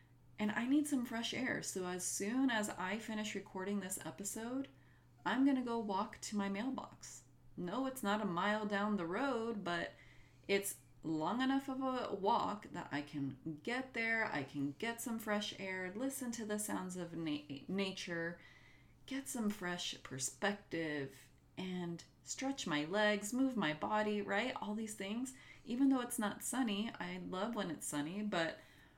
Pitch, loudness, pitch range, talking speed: 205 Hz, -40 LUFS, 170-230 Hz, 170 wpm